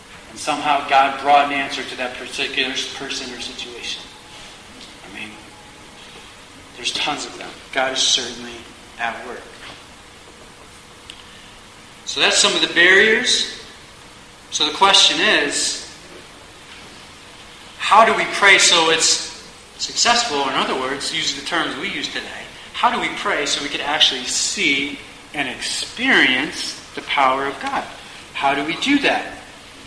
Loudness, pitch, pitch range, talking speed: -17 LUFS, 135 Hz, 125-160 Hz, 135 wpm